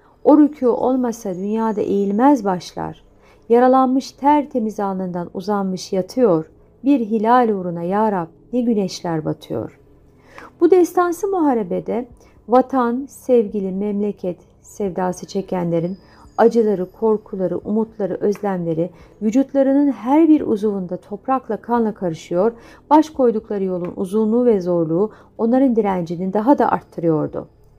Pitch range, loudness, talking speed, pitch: 185-250 Hz, -19 LUFS, 110 wpm, 215 Hz